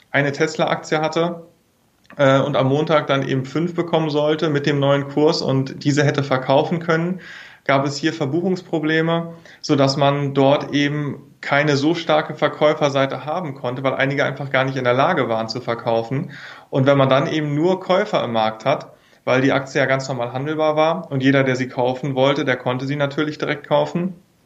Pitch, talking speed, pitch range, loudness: 145 Hz, 190 wpm, 135-155 Hz, -19 LUFS